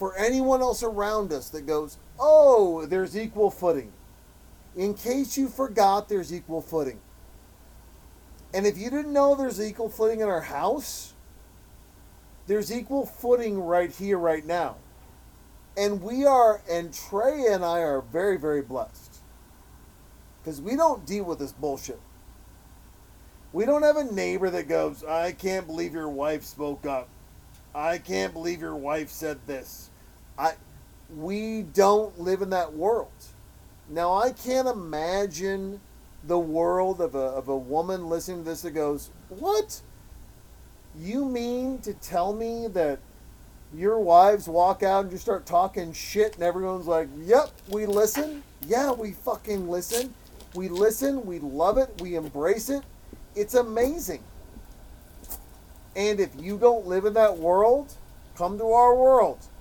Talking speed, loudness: 145 wpm, -25 LUFS